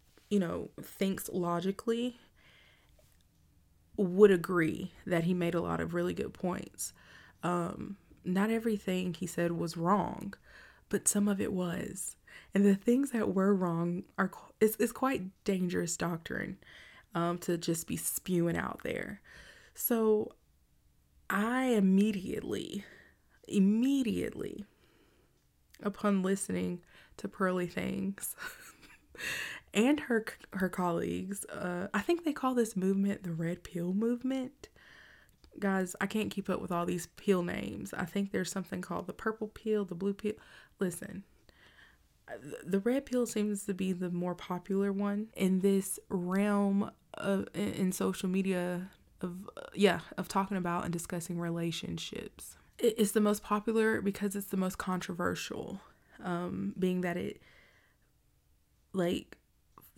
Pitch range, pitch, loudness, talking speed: 175-210 Hz, 195 Hz, -33 LUFS, 135 wpm